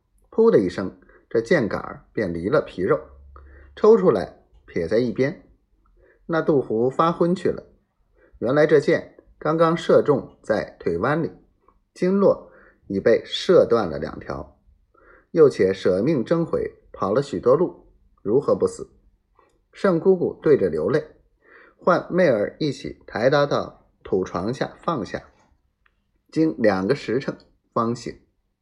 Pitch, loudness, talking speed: 215 Hz, -21 LUFS, 185 characters per minute